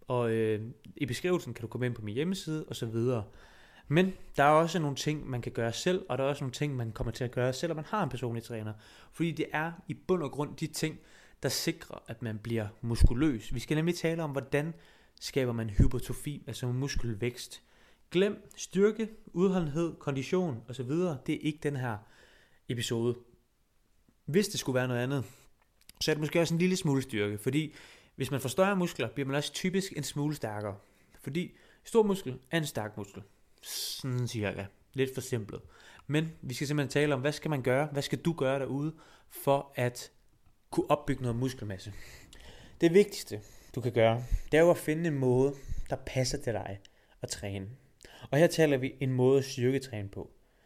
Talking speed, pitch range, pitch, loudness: 200 wpm, 120-155 Hz, 135 Hz, -32 LUFS